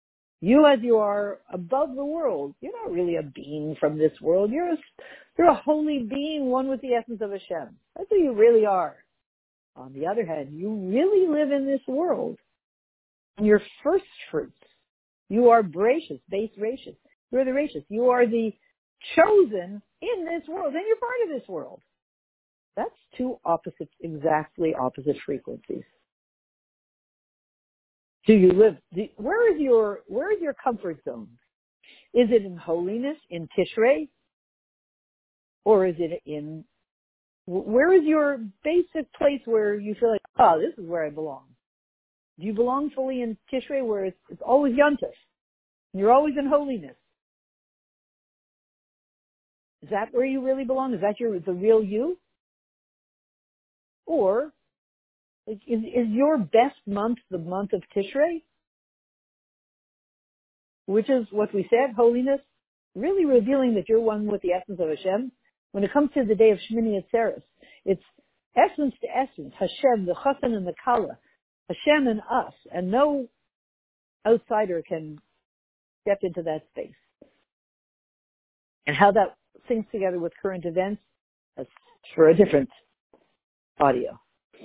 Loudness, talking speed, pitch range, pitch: -24 LUFS, 145 wpm, 190-275 Hz, 225 Hz